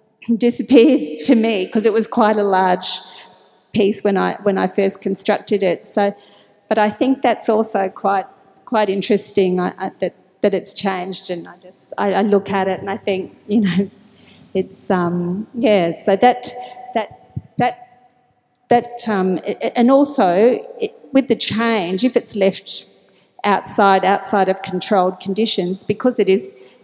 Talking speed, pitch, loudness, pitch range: 160 wpm, 205 Hz, -17 LUFS, 190-235 Hz